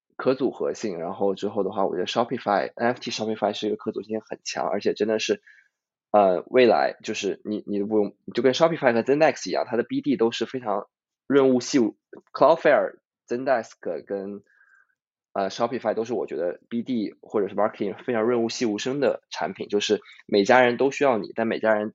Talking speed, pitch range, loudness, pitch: 410 characters per minute, 105-135 Hz, -24 LUFS, 115 Hz